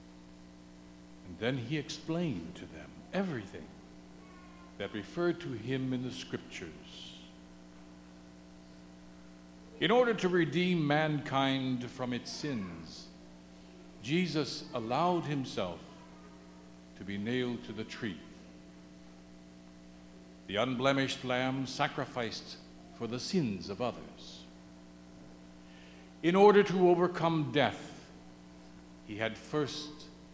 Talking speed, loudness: 95 wpm, -33 LUFS